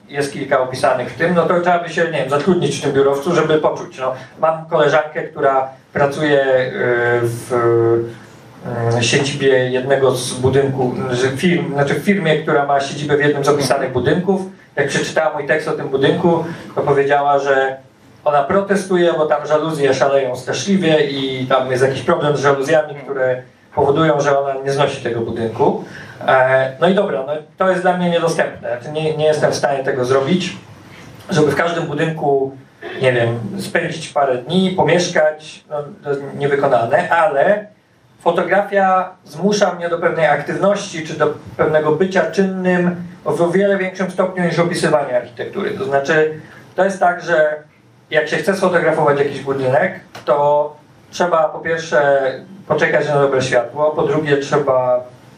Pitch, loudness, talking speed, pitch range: 150 Hz, -16 LUFS, 155 wpm, 135-170 Hz